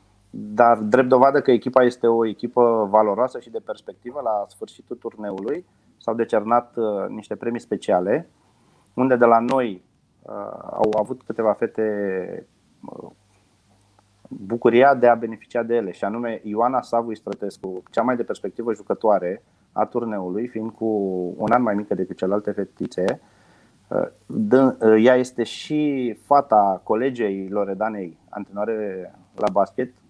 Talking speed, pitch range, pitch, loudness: 130 wpm, 105-120 Hz, 110 Hz, -21 LUFS